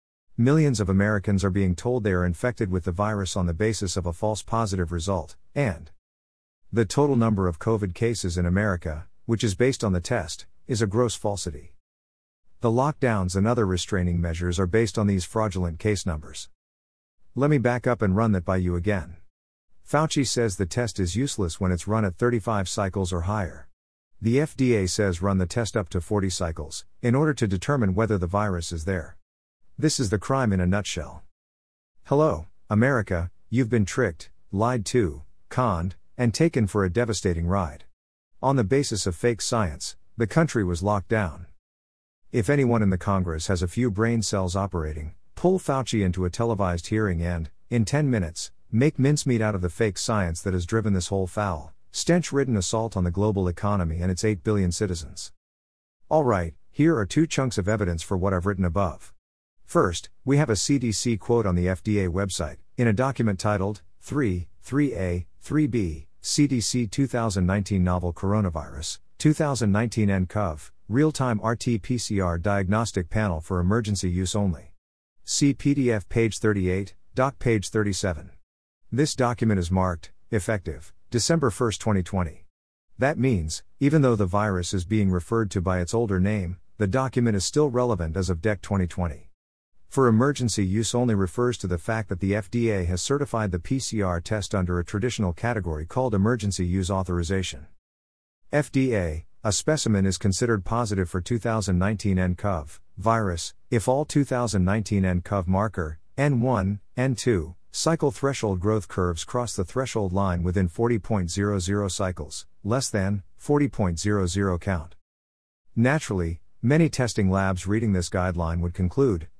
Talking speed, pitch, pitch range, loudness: 160 wpm, 100 Hz, 90-115 Hz, -25 LUFS